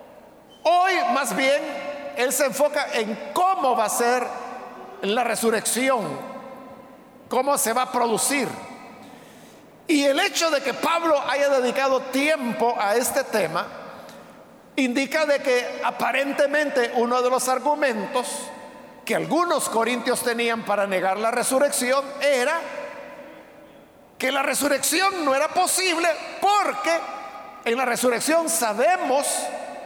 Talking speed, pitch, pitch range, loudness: 115 wpm, 270 Hz, 245-295 Hz, -22 LUFS